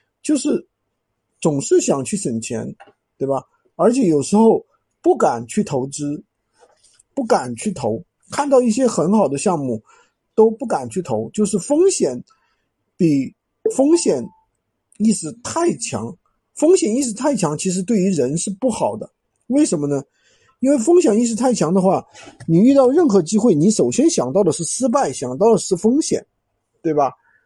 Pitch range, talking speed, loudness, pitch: 185-280 Hz, 225 characters per minute, -18 LUFS, 220 Hz